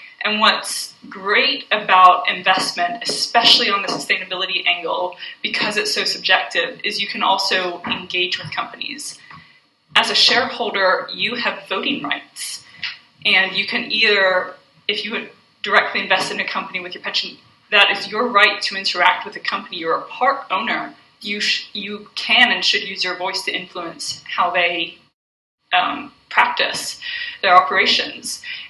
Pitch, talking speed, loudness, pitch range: 200 Hz, 155 wpm, -17 LUFS, 185-235 Hz